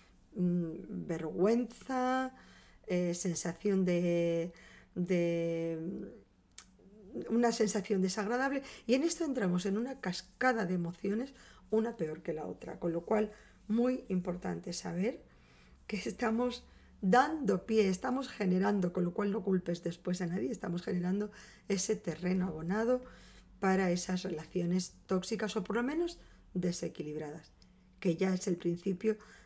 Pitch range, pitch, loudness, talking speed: 175-220 Hz, 190 Hz, -34 LUFS, 125 wpm